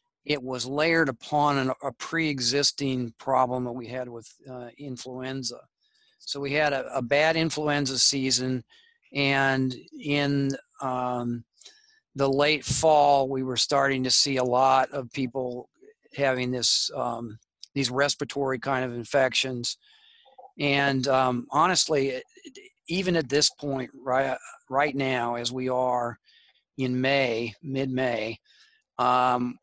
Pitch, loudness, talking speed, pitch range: 135 Hz, -25 LUFS, 130 wpm, 125-145 Hz